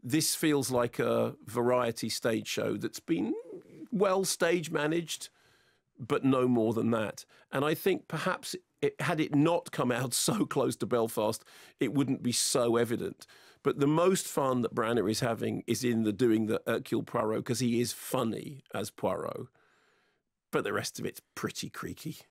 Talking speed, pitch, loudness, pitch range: 170 wpm, 130 Hz, -31 LUFS, 115-165 Hz